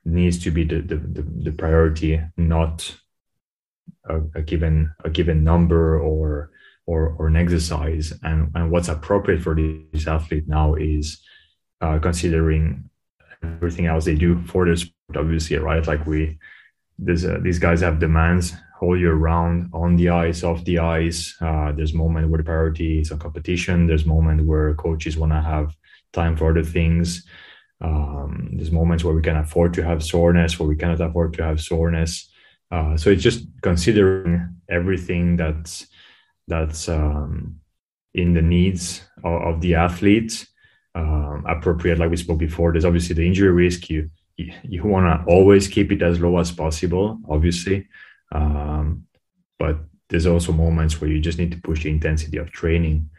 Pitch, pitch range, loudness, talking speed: 85 Hz, 80-85 Hz, -20 LUFS, 165 wpm